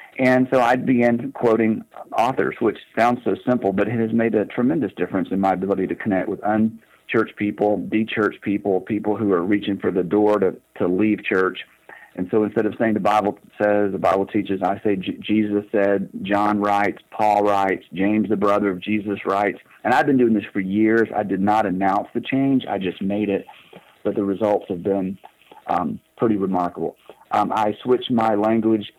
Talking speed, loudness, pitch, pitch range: 195 wpm, -21 LUFS, 105 Hz, 100-110 Hz